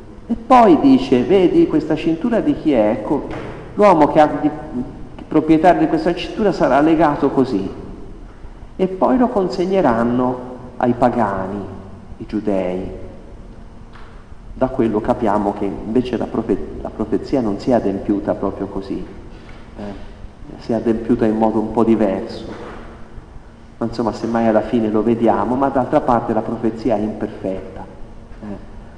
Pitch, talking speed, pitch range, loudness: 115 Hz, 140 wpm, 105-150 Hz, -17 LUFS